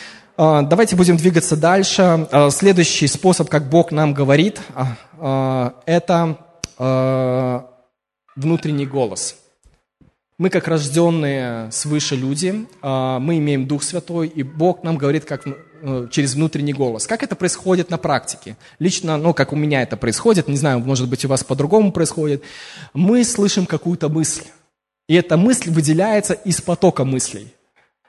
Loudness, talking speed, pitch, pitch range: -17 LUFS, 130 wpm, 155 Hz, 140-175 Hz